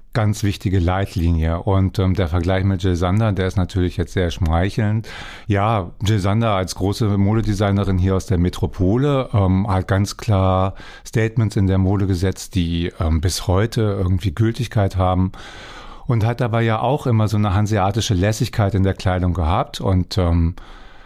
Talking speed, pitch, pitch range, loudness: 165 wpm, 95 Hz, 95-110 Hz, -19 LUFS